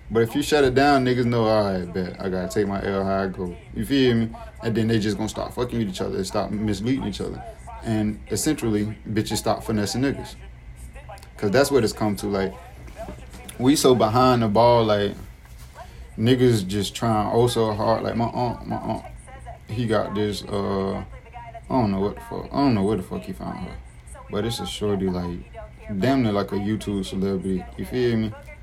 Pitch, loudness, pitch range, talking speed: 105 Hz, -23 LUFS, 95-115 Hz, 205 wpm